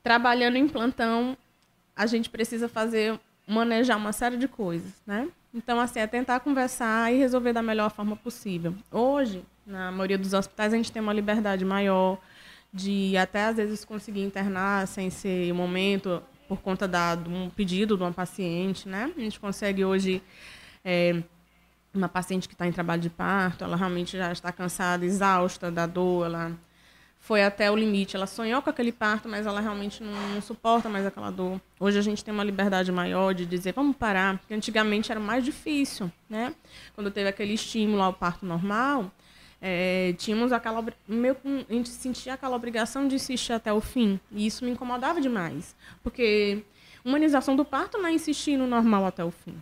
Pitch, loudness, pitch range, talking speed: 210 Hz, -27 LUFS, 185-235 Hz, 180 wpm